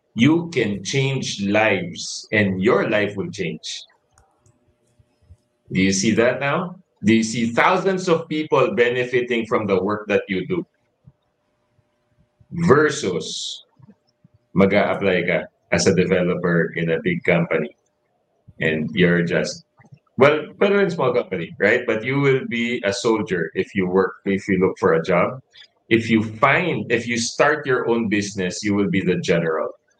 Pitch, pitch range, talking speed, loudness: 120 Hz, 100-135 Hz, 150 wpm, -20 LUFS